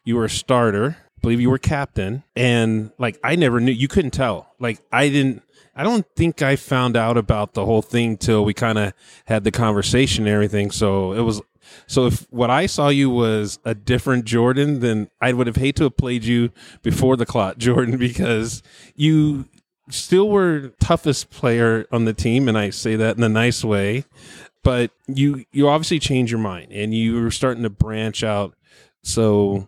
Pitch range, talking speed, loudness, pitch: 110-135 Hz, 200 wpm, -19 LUFS, 120 Hz